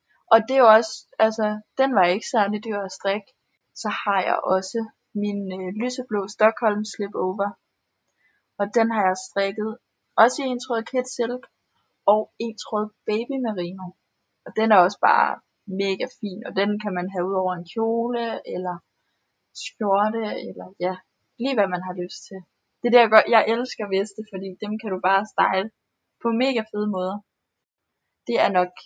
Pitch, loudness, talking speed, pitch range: 210 Hz, -23 LUFS, 170 wpm, 190-230 Hz